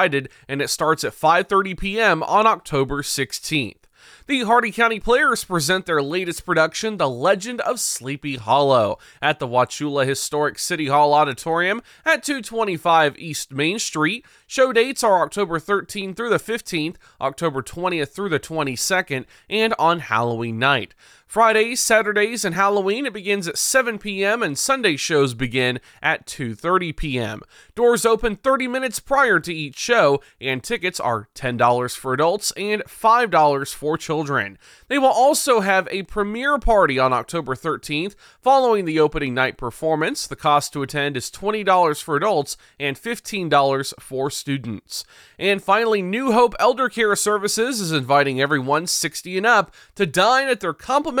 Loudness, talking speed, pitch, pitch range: -20 LUFS, 155 wpm, 170 Hz, 140-220 Hz